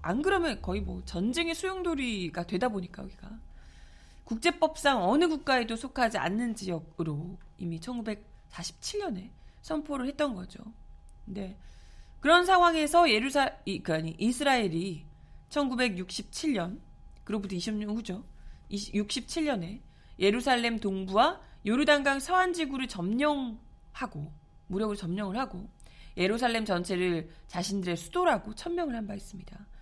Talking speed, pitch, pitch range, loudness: 280 characters per minute, 220 Hz, 185-280 Hz, -30 LUFS